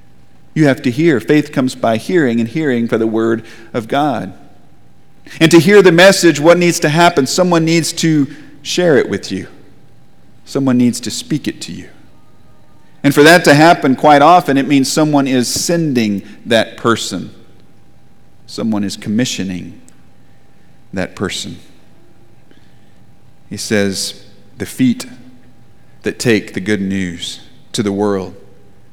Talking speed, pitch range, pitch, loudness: 145 wpm, 110-160 Hz, 130 Hz, -13 LUFS